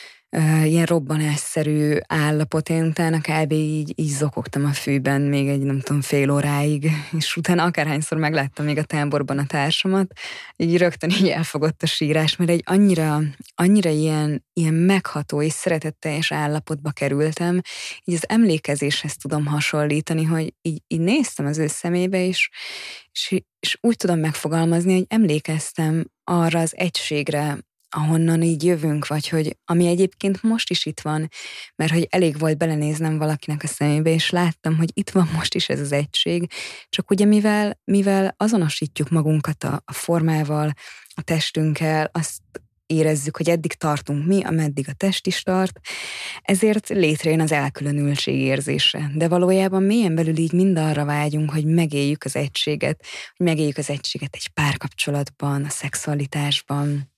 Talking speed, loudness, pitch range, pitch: 150 wpm, -21 LUFS, 150-175 Hz, 155 Hz